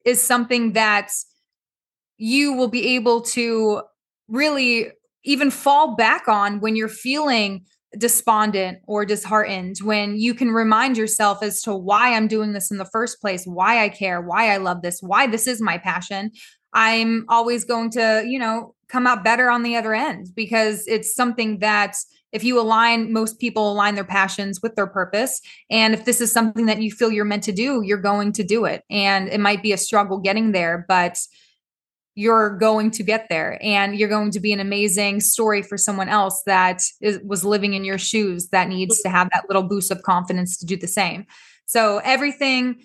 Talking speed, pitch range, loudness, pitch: 195 wpm, 200-230 Hz, -19 LUFS, 215 Hz